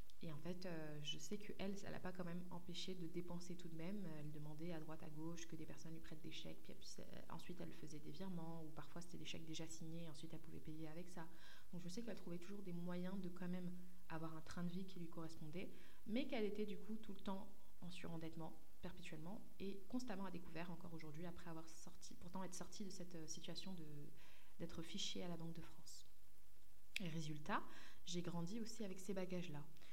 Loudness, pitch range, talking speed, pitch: -53 LUFS, 160-185 Hz, 230 wpm, 175 Hz